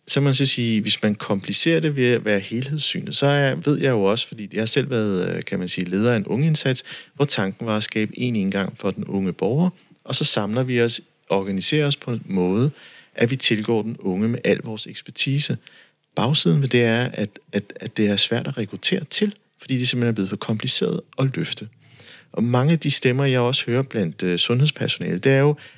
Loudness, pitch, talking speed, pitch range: -20 LUFS, 120 Hz, 220 wpm, 105-140 Hz